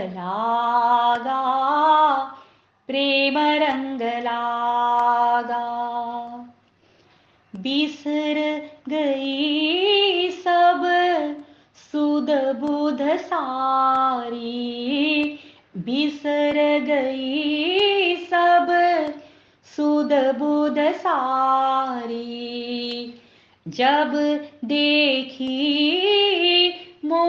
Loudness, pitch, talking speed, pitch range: -21 LUFS, 290 Hz, 35 wpm, 245-300 Hz